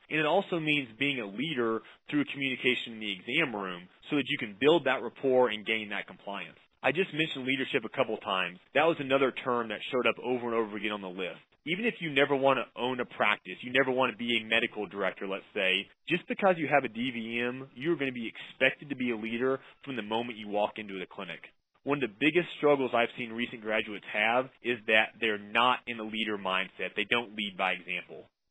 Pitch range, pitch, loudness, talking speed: 110-135 Hz, 120 Hz, -30 LUFS, 235 wpm